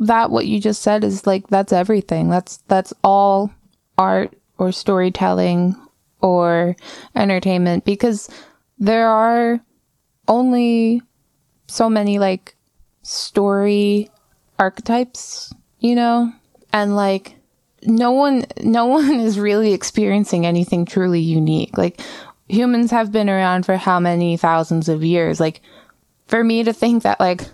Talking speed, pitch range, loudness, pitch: 125 wpm, 185-230 Hz, -17 LUFS, 205 Hz